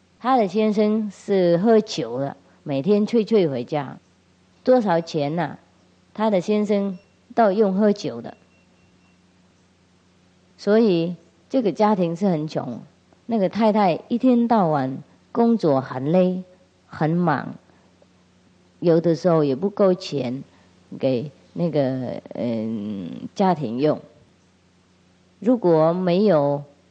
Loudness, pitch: -21 LUFS, 170 Hz